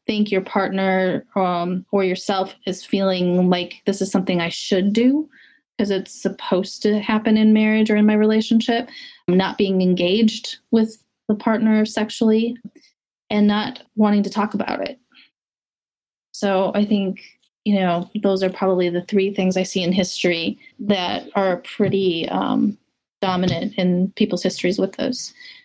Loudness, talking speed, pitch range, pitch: -20 LUFS, 155 wpm, 185-220 Hz, 200 Hz